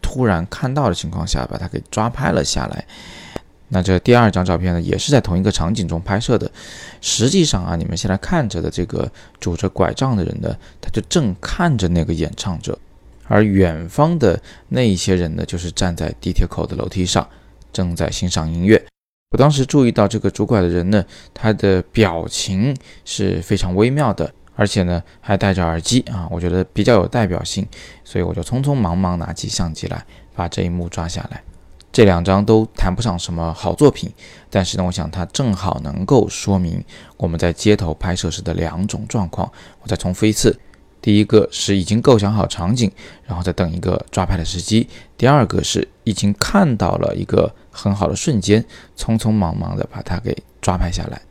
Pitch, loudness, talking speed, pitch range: 95 Hz, -18 LUFS, 290 characters per minute, 85-110 Hz